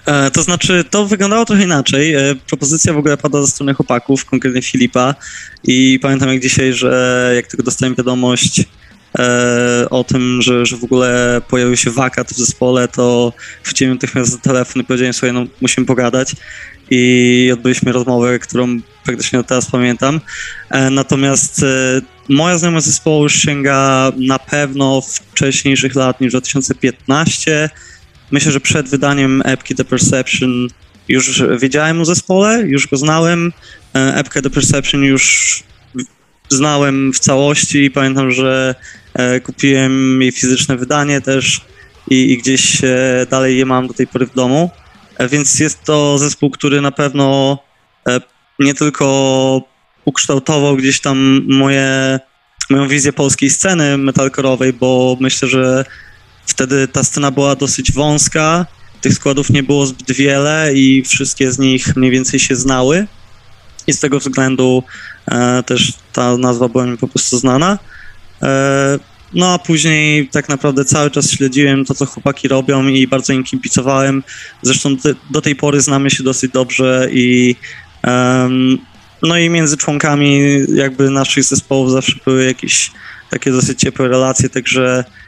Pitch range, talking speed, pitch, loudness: 130-140 Hz, 150 wpm, 135 Hz, -12 LUFS